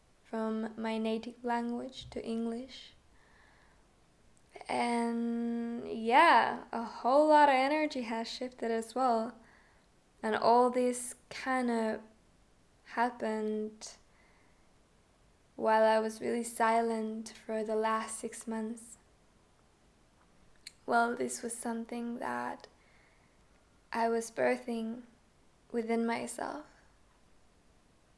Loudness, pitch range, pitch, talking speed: -32 LUFS, 220-235 Hz, 230 Hz, 90 wpm